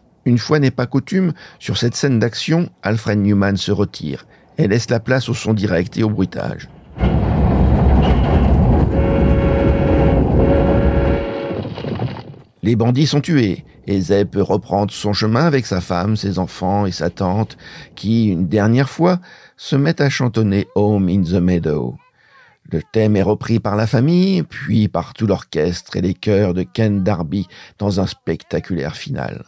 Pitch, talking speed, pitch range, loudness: 105 Hz, 150 wpm, 90-120 Hz, -17 LUFS